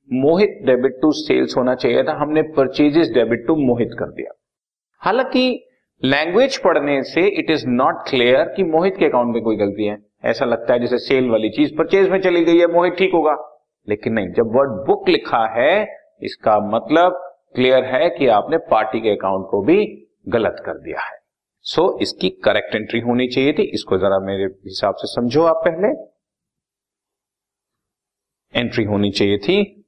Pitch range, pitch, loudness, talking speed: 115-180 Hz, 140 Hz, -17 LUFS, 175 wpm